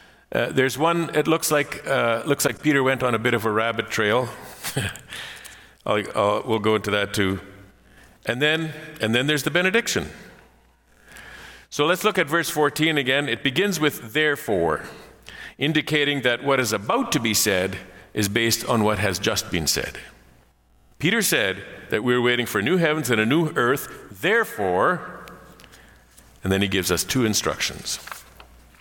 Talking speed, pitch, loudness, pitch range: 165 wpm, 120 Hz, -22 LUFS, 105-150 Hz